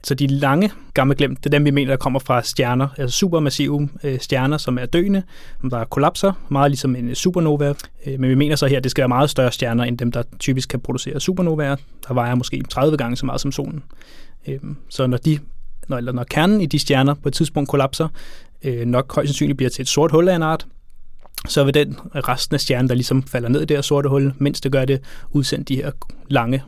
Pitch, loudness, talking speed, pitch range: 140 Hz, -19 LUFS, 225 wpm, 130-145 Hz